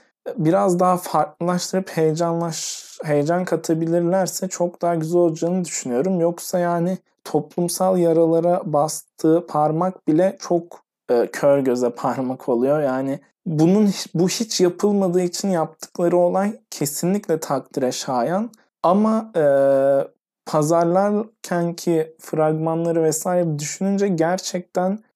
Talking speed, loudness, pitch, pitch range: 100 wpm, -20 LUFS, 175 Hz, 155-185 Hz